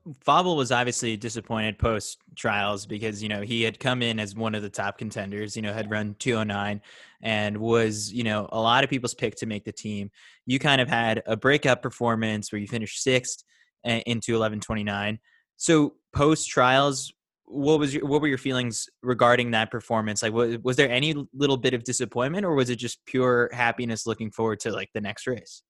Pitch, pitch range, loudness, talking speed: 115 Hz, 110-130 Hz, -25 LUFS, 200 wpm